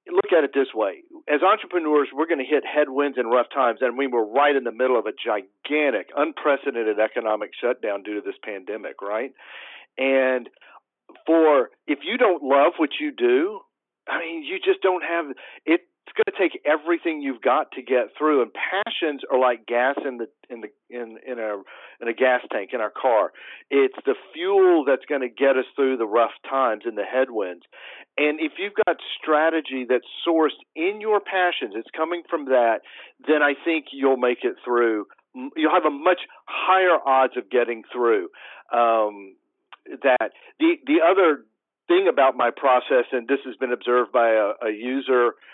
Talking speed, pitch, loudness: 185 wpm, 145 Hz, -22 LUFS